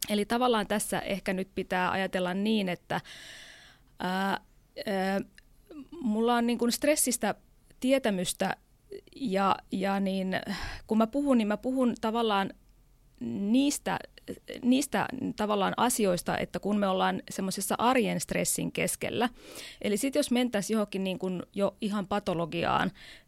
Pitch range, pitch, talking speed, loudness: 190-240 Hz, 210 Hz, 125 wpm, -29 LUFS